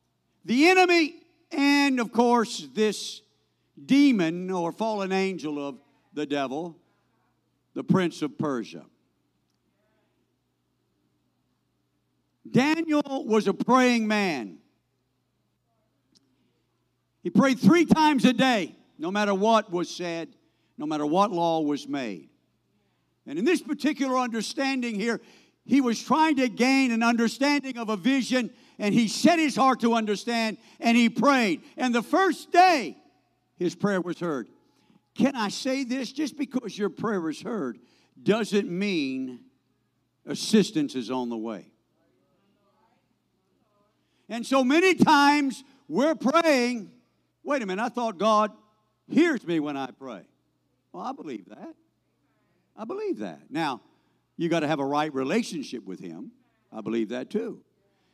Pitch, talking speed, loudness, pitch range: 225 Hz, 130 wpm, -25 LUFS, 170-270 Hz